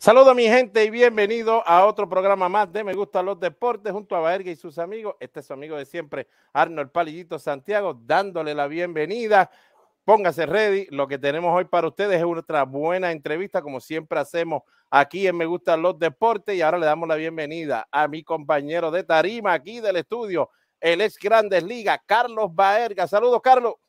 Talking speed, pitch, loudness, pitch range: 190 wpm, 175 Hz, -21 LUFS, 160-205 Hz